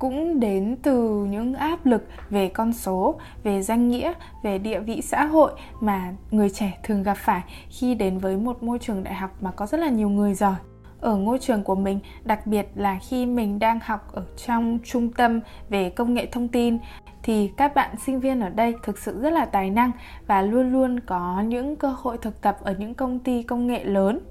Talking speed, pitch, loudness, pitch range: 215 wpm, 225 Hz, -24 LUFS, 200-250 Hz